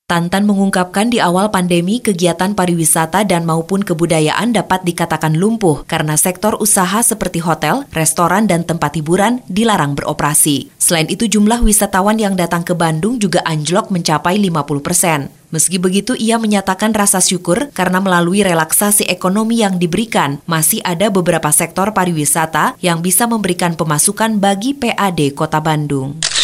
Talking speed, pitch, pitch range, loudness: 140 wpm, 185 Hz, 165-205 Hz, -13 LUFS